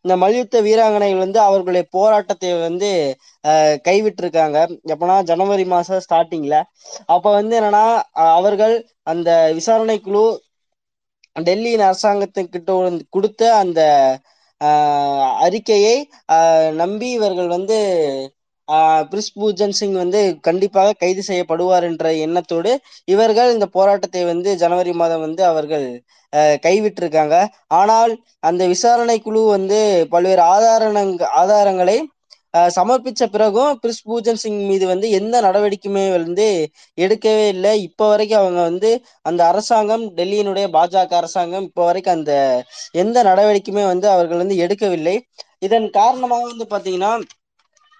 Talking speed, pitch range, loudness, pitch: 110 wpm, 170-215 Hz, -16 LUFS, 195 Hz